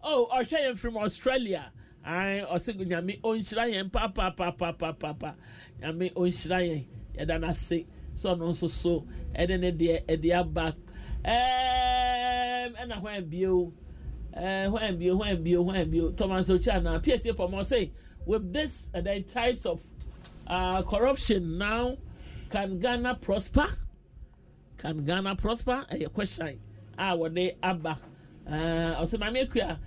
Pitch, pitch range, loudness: 185 Hz, 165-220 Hz, -30 LUFS